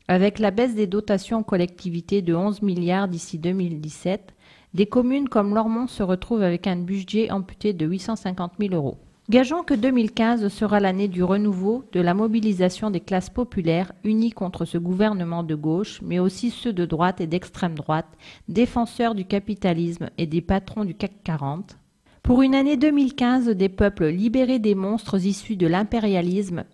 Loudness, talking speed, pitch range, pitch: -23 LUFS, 165 wpm, 180-225 Hz, 200 Hz